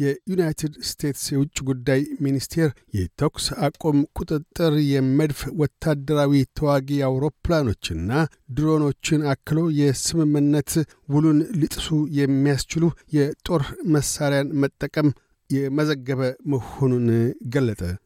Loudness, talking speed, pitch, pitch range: -22 LUFS, 80 wpm, 145 Hz, 135-155 Hz